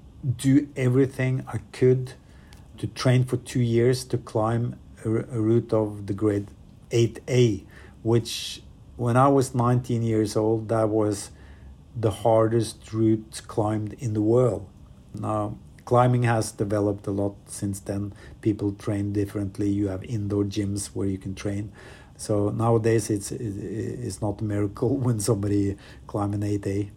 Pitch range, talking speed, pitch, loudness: 100-120 Hz, 140 wpm, 110 Hz, -25 LUFS